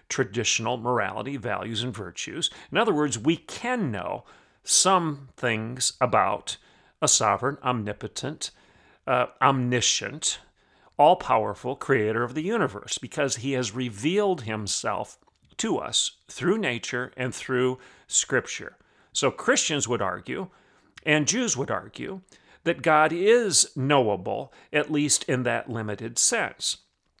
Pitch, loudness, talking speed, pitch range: 125 Hz, -25 LUFS, 120 wpm, 115-150 Hz